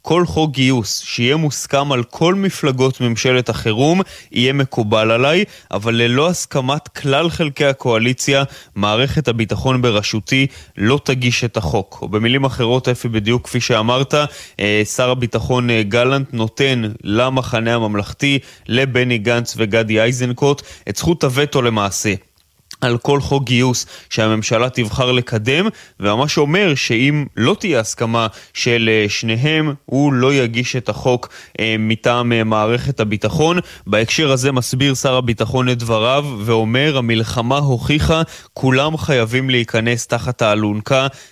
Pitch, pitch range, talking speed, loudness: 125 Hz, 115-140 Hz, 125 wpm, -16 LUFS